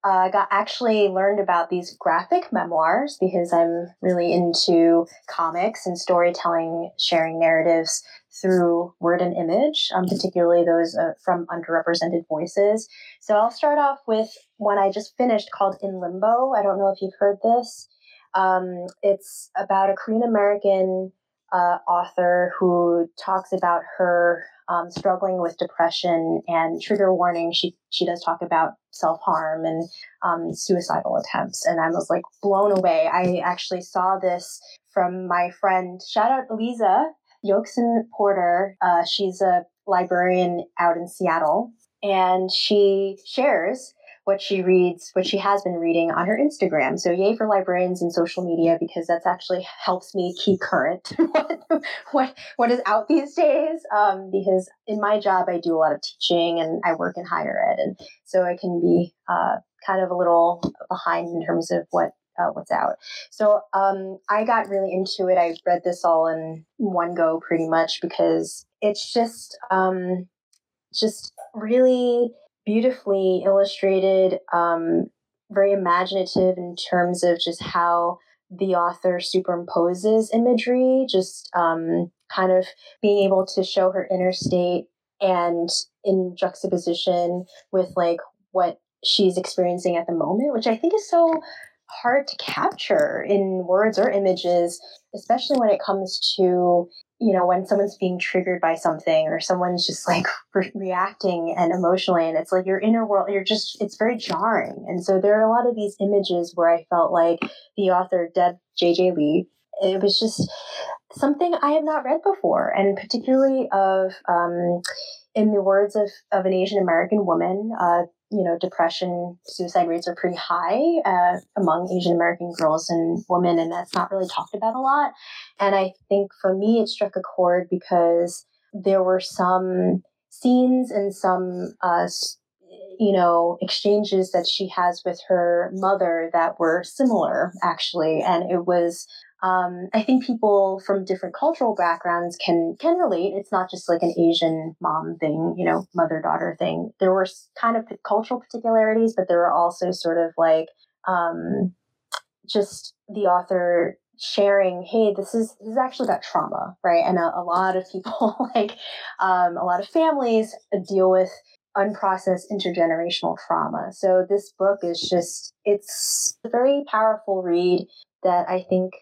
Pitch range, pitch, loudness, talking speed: 175-210 Hz, 185 Hz, -22 LUFS, 160 wpm